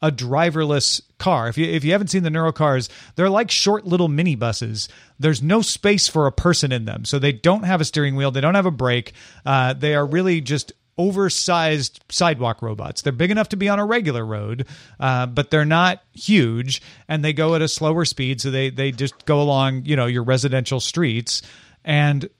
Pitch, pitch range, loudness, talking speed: 150 Hz, 130-170 Hz, -19 LUFS, 210 wpm